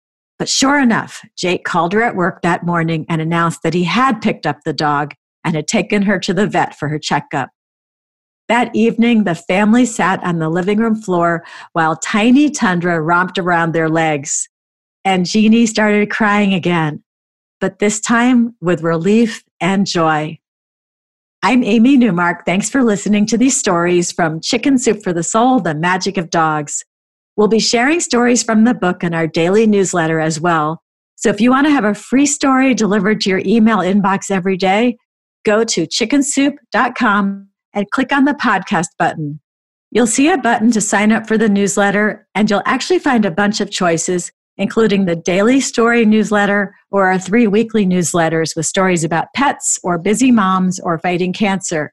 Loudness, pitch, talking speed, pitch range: -14 LUFS, 200 Hz, 175 wpm, 175-230 Hz